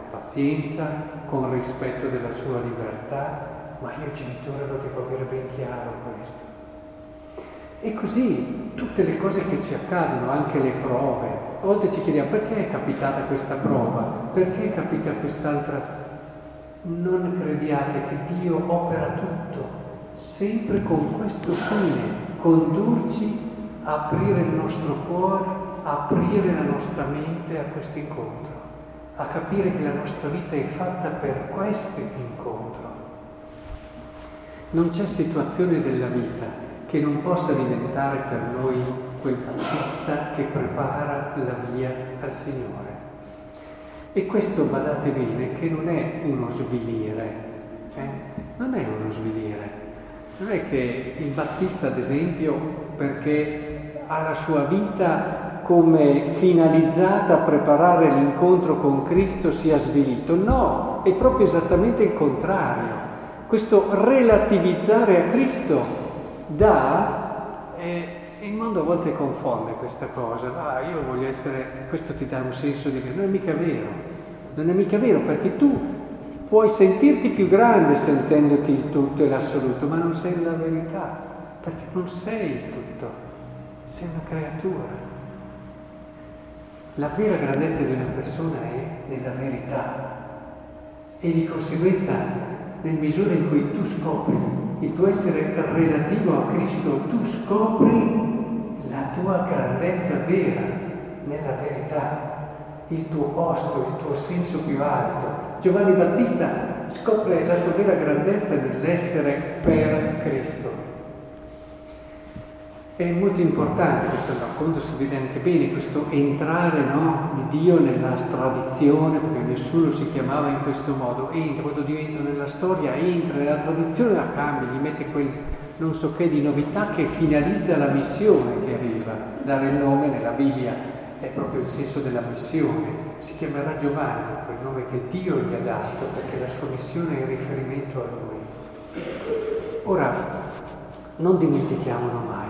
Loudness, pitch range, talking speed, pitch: -23 LUFS, 140-180 Hz, 135 wpm, 155 Hz